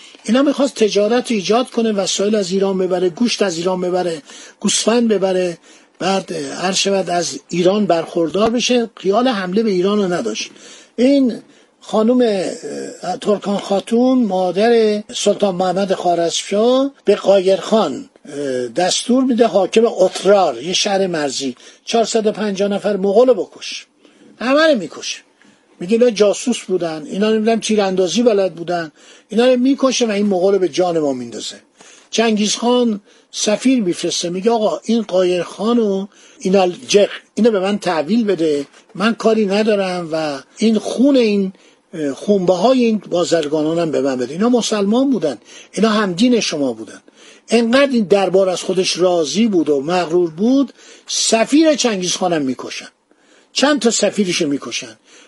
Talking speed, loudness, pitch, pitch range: 135 wpm, -16 LUFS, 205 Hz, 180-230 Hz